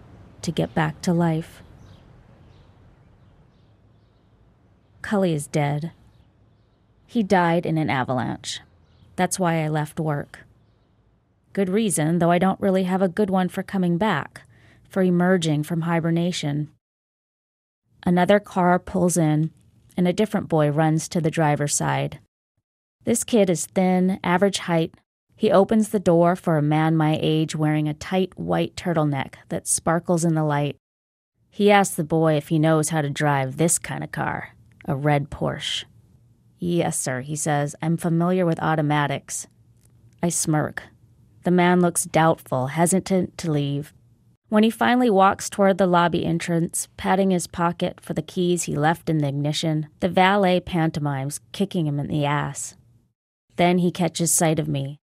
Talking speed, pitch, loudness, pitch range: 150 wpm, 160 Hz, -22 LUFS, 145-180 Hz